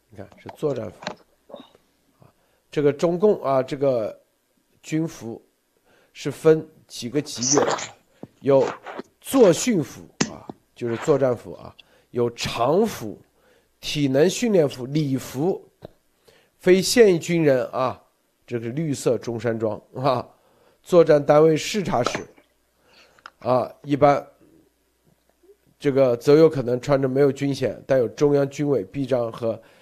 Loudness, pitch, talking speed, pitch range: -21 LUFS, 145 Hz, 175 characters per minute, 125-160 Hz